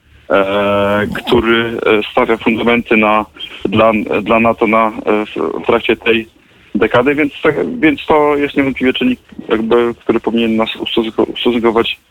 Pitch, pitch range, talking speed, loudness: 115 Hz, 110-120 Hz, 130 wpm, -13 LUFS